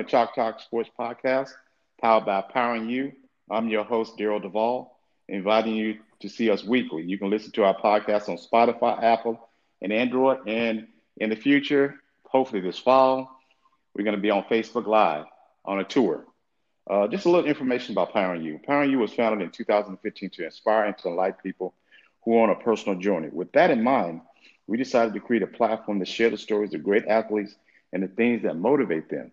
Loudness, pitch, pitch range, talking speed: -25 LUFS, 115 Hz, 105-125 Hz, 195 wpm